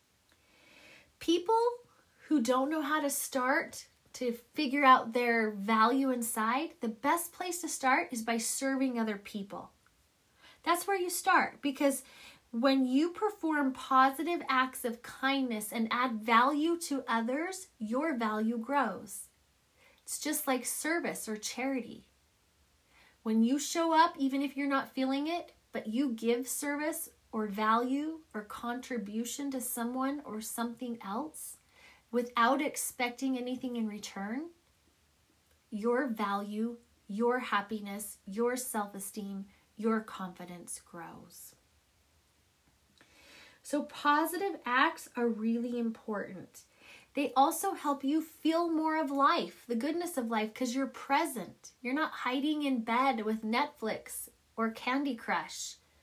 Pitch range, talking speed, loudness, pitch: 230-285 Hz, 125 wpm, -32 LUFS, 255 Hz